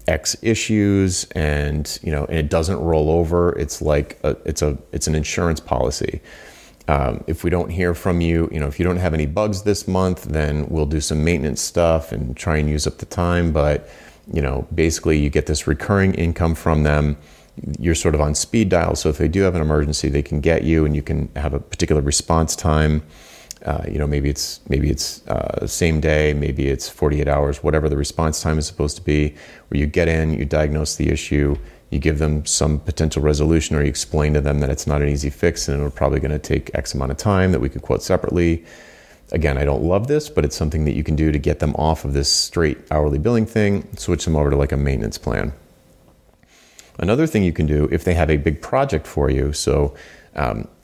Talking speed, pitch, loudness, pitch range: 230 wpm, 75 Hz, -20 LUFS, 75-85 Hz